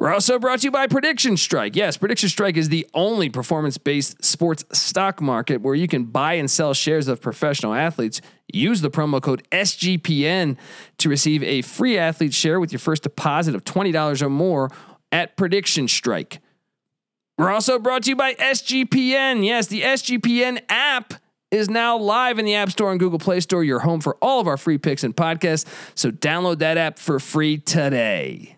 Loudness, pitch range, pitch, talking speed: -20 LUFS, 150-205 Hz, 165 Hz, 185 wpm